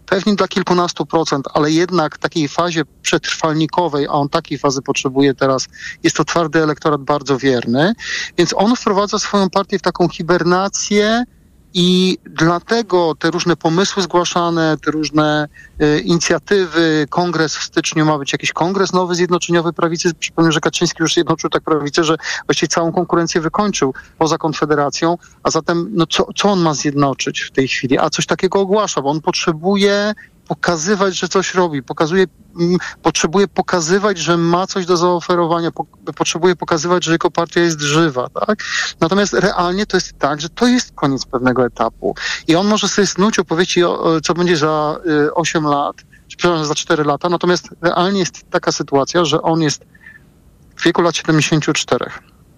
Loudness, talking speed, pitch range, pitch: -16 LUFS, 165 wpm, 155-180 Hz, 170 Hz